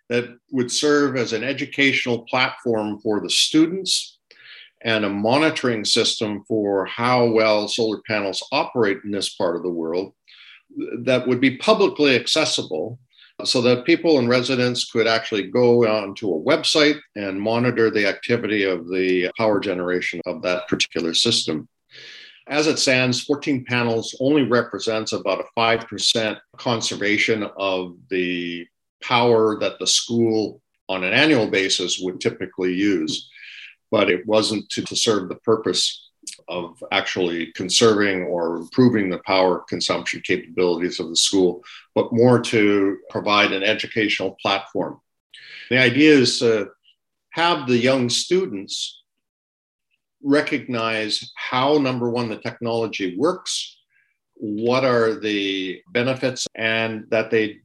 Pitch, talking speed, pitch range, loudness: 115 Hz, 130 wpm, 100-125 Hz, -20 LUFS